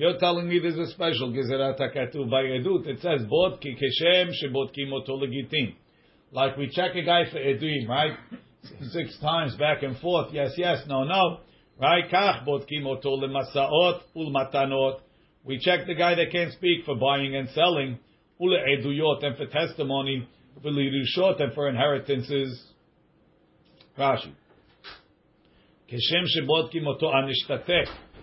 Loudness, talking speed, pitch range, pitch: -25 LUFS, 130 wpm, 135-170 Hz, 140 Hz